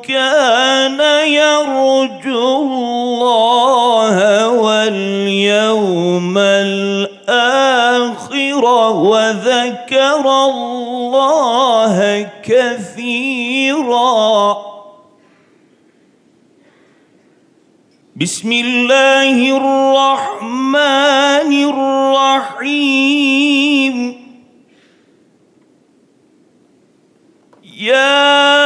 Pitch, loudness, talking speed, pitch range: 255 Hz, -12 LUFS, 25 wpm, 225-275 Hz